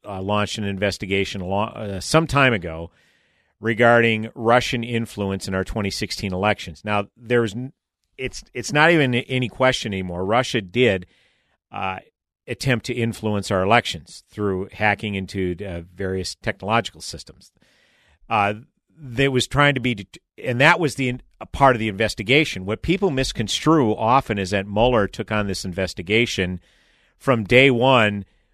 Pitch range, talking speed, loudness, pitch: 95-125 Hz, 155 wpm, -21 LUFS, 110 Hz